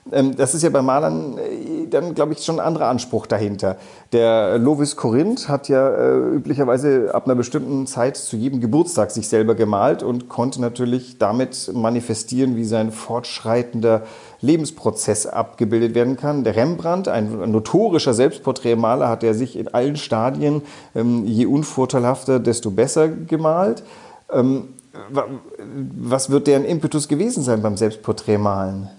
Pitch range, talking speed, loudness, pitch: 115-140 Hz, 135 wpm, -19 LUFS, 125 Hz